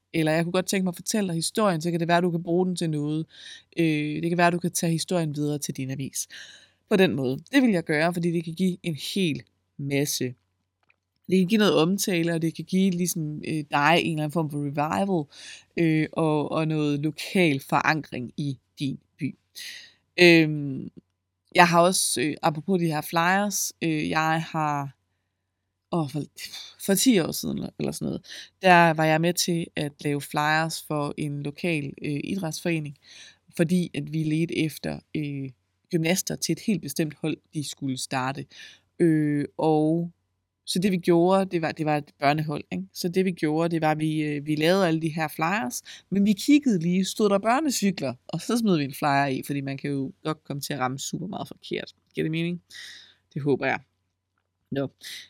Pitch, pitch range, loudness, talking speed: 160 Hz, 145-175 Hz, -25 LUFS, 195 wpm